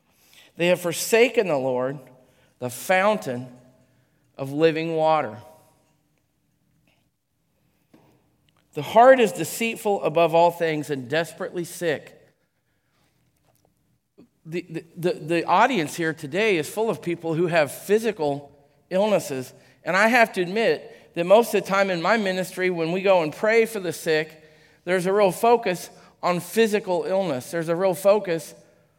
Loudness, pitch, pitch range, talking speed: -22 LUFS, 170 Hz, 155-195 Hz, 140 wpm